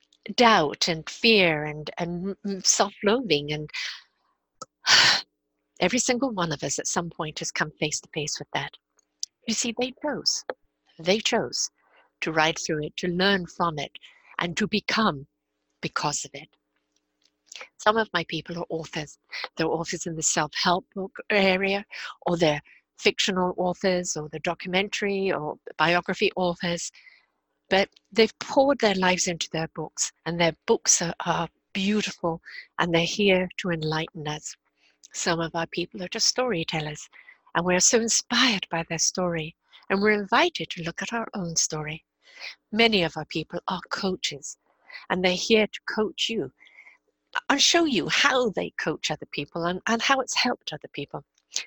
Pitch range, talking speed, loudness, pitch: 160-215 Hz, 155 wpm, -25 LUFS, 180 Hz